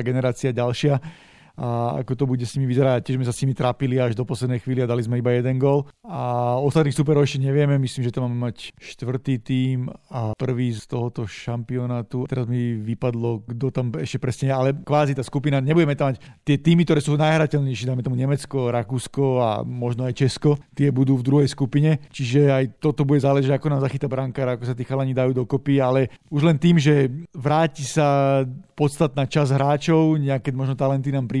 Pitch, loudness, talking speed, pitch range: 135 Hz, -22 LUFS, 200 wpm, 125-145 Hz